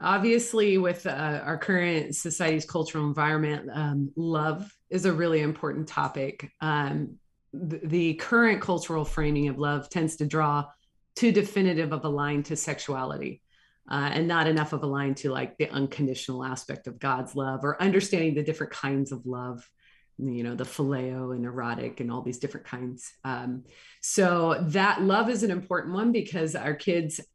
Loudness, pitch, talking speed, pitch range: -28 LUFS, 155 Hz, 170 wpm, 140-170 Hz